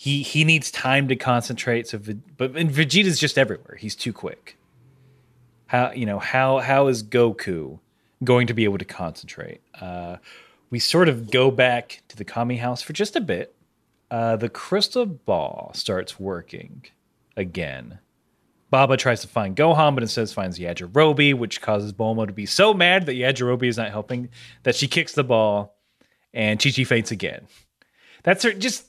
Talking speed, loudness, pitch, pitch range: 175 wpm, -21 LUFS, 125 Hz, 110-140 Hz